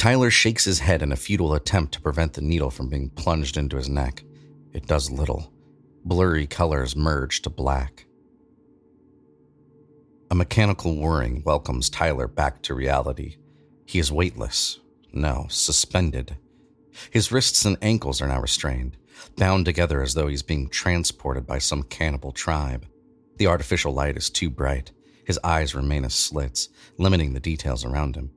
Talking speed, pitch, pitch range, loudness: 155 wpm, 75 Hz, 70-85 Hz, -23 LUFS